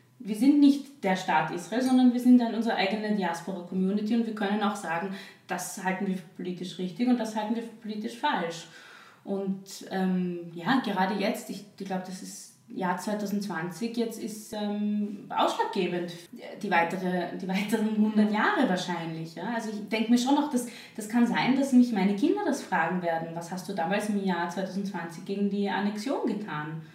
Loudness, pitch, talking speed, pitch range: -28 LUFS, 205 Hz, 185 wpm, 185-230 Hz